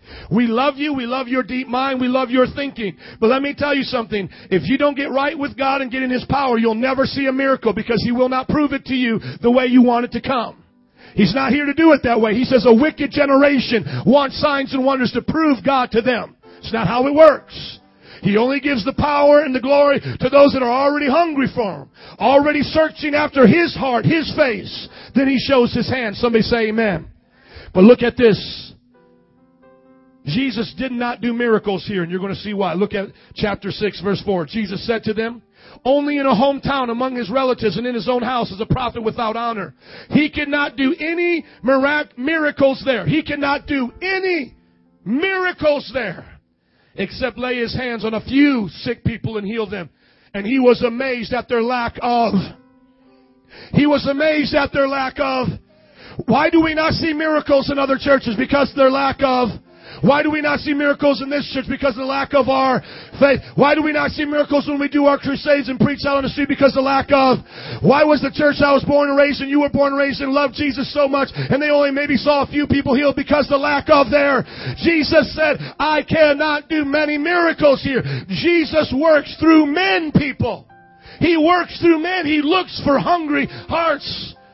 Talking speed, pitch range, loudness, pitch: 210 wpm, 235-290 Hz, -17 LUFS, 265 Hz